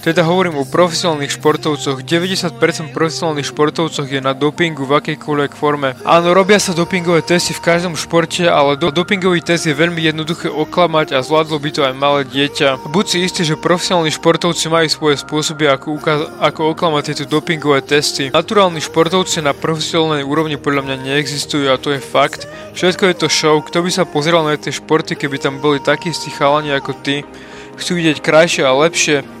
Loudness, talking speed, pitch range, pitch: -14 LUFS, 180 wpm, 145-170 Hz, 155 Hz